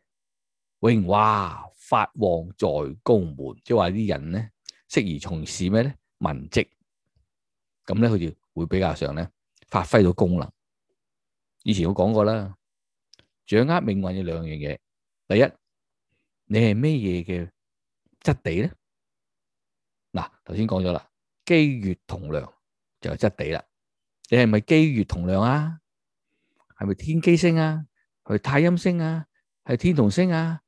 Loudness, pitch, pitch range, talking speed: -23 LUFS, 105 Hz, 90-145 Hz, 190 characters per minute